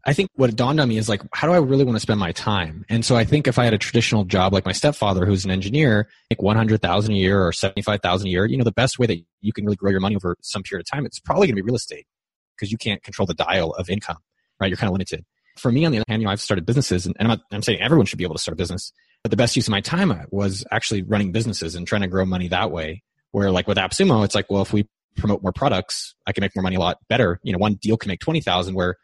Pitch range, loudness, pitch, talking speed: 95-115 Hz, -21 LUFS, 105 Hz, 315 wpm